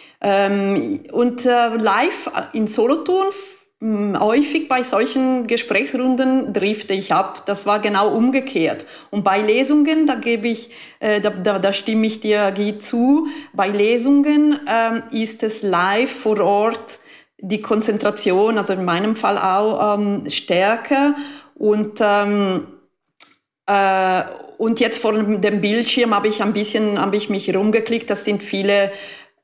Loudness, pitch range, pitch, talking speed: -18 LUFS, 205-250 Hz, 220 Hz, 130 wpm